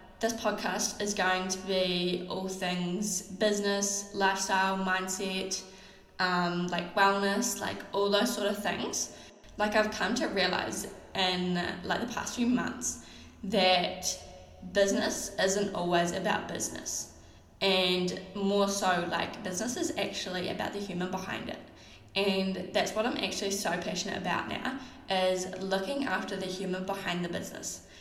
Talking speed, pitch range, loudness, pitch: 140 wpm, 185-205 Hz, -30 LUFS, 190 Hz